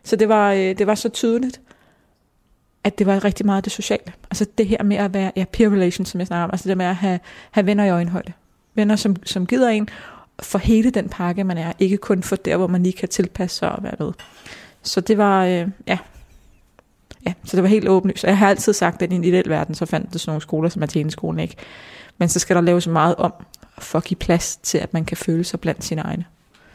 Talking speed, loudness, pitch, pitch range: 240 wpm, -20 LUFS, 190 Hz, 175-205 Hz